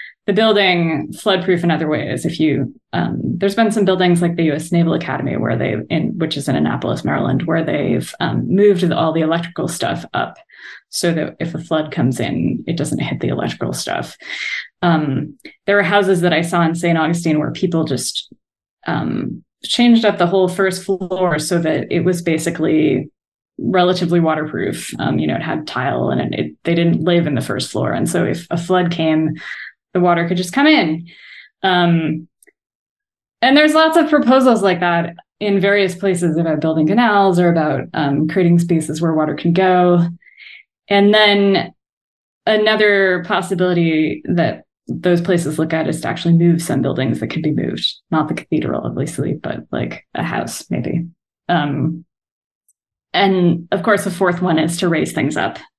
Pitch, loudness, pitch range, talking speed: 170 Hz, -16 LUFS, 160-190 Hz, 180 wpm